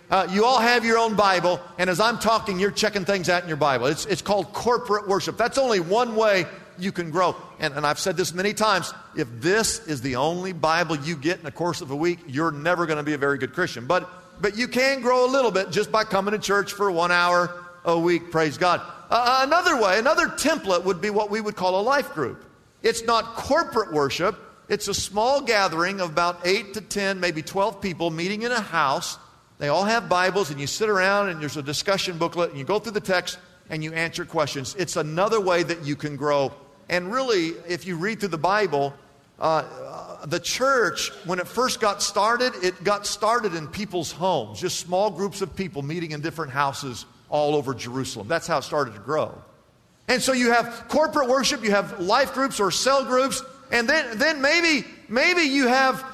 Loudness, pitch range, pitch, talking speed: -23 LUFS, 170-220 Hz, 190 Hz, 220 wpm